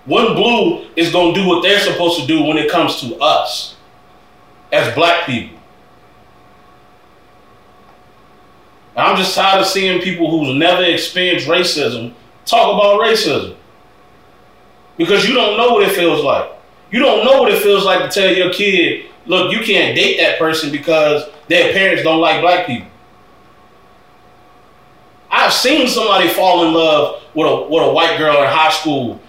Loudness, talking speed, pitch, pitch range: -13 LUFS, 165 wpm, 180 Hz, 160-200 Hz